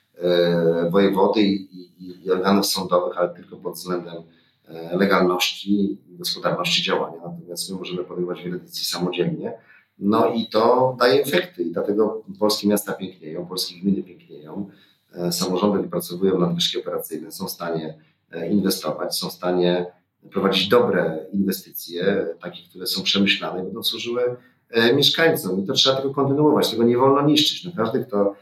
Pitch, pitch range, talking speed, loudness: 95 Hz, 90-110 Hz, 155 wpm, -21 LUFS